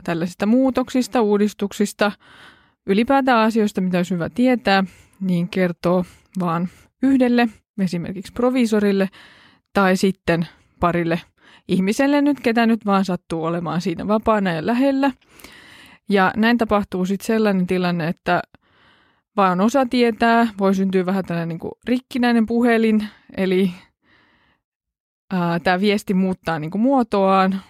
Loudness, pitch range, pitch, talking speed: -19 LUFS, 185-230 Hz, 200 Hz, 115 wpm